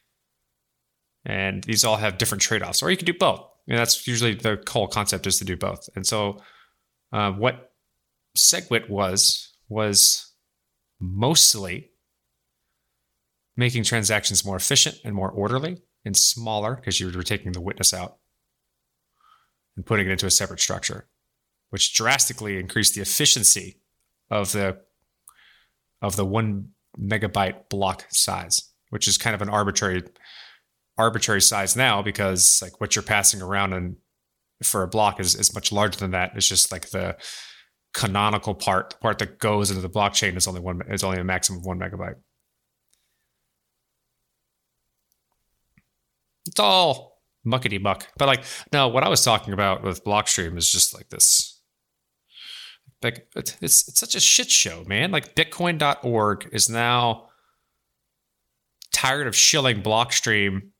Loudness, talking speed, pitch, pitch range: -20 LUFS, 150 wpm, 100 Hz, 95-115 Hz